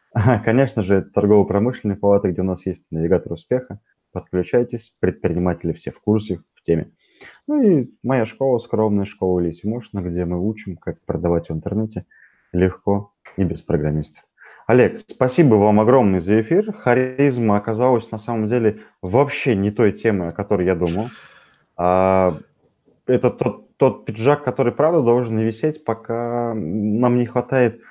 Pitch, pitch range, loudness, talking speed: 110 Hz, 95-120 Hz, -19 LUFS, 145 wpm